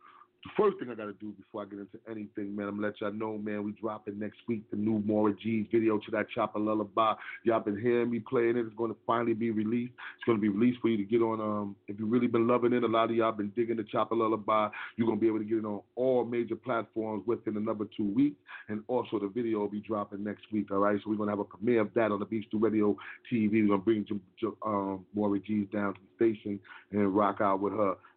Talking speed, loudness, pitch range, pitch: 280 wpm, -31 LUFS, 105-115 Hz, 110 Hz